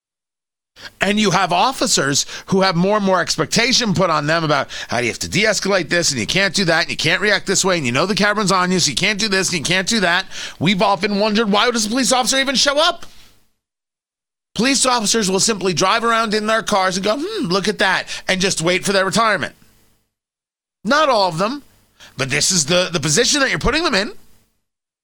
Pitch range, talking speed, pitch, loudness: 180-225 Hz, 230 wpm, 195 Hz, -16 LUFS